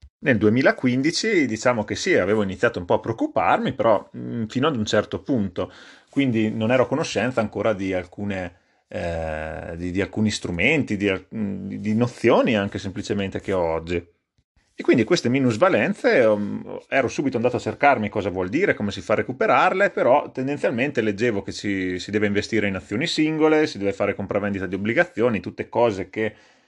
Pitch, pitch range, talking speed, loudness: 105 Hz, 95-115 Hz, 170 wpm, -22 LUFS